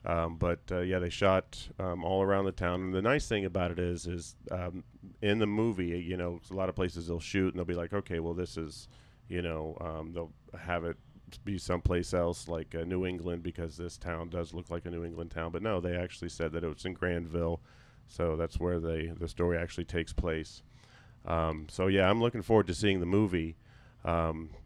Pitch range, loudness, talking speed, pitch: 85-95 Hz, -33 LUFS, 225 wpm, 90 Hz